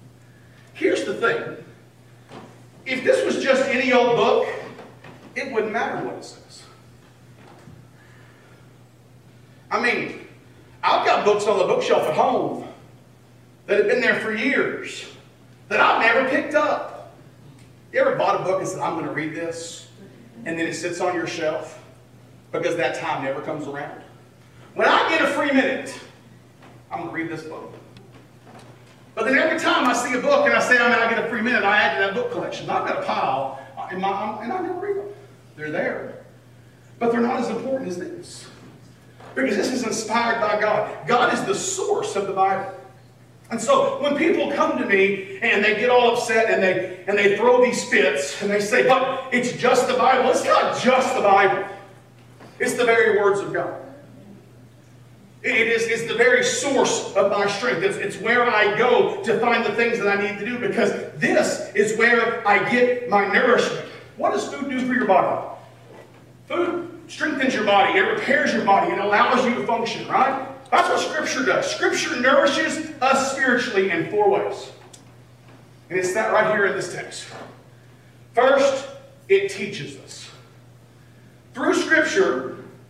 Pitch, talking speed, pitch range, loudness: 220 Hz, 180 wpm, 175-265 Hz, -20 LUFS